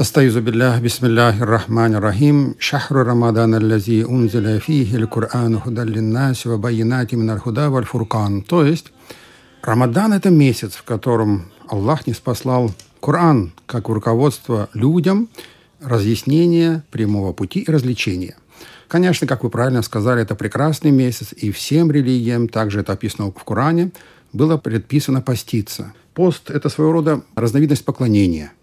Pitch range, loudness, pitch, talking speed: 110-145 Hz, -17 LUFS, 120 Hz, 95 wpm